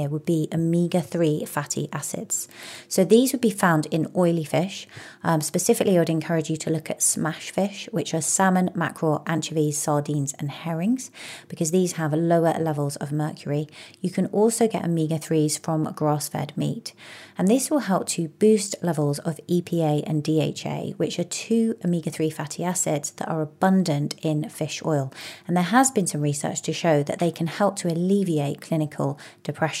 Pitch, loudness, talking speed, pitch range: 165 Hz, -24 LUFS, 180 wpm, 155-180 Hz